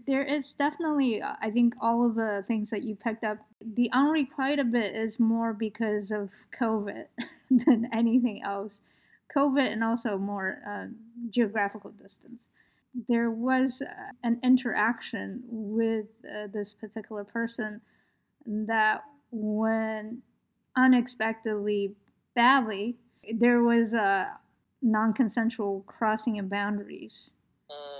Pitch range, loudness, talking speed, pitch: 215-245 Hz, -28 LUFS, 115 wpm, 230 Hz